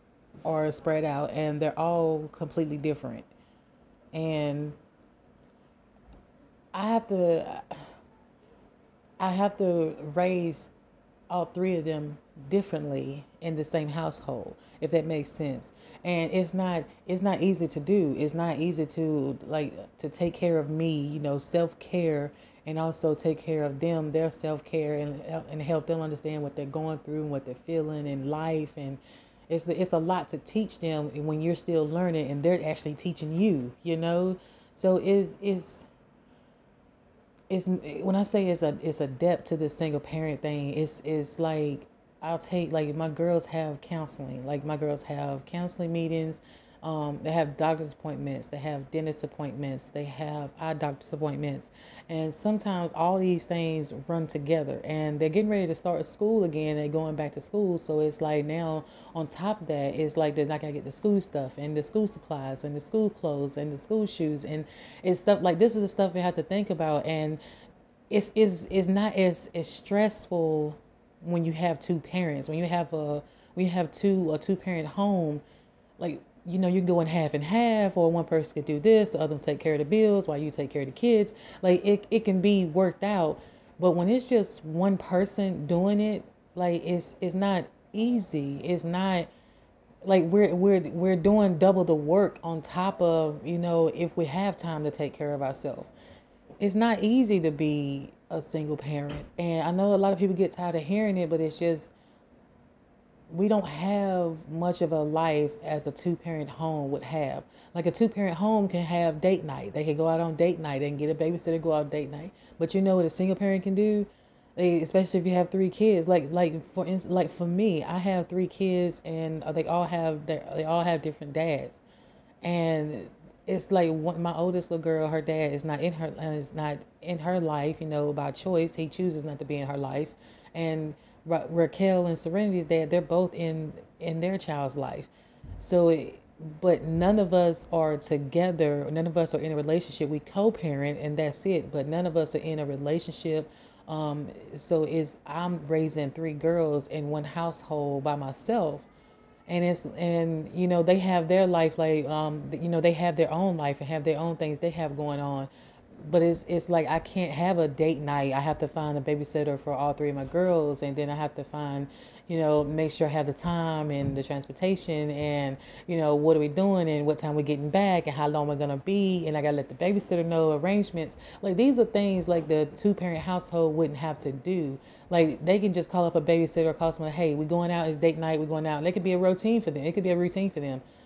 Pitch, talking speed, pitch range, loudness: 165 Hz, 205 wpm, 150-180 Hz, -28 LUFS